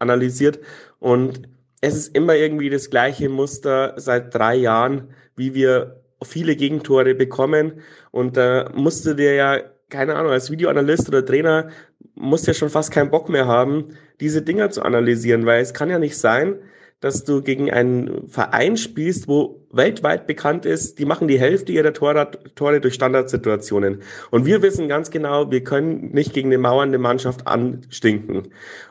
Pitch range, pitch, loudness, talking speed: 125-150 Hz, 135 Hz, -19 LUFS, 165 wpm